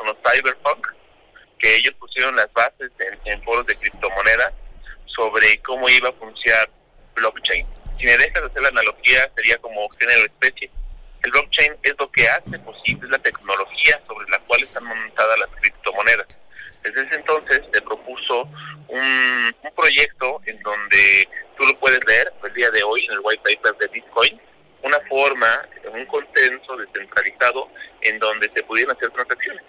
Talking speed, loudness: 160 wpm, -17 LUFS